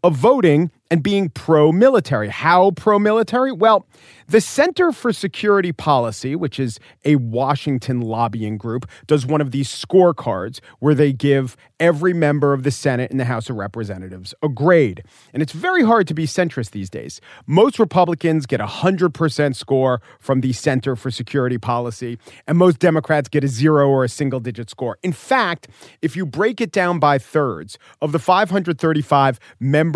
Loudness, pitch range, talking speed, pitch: -18 LUFS, 125-175 Hz, 170 wpm, 150 Hz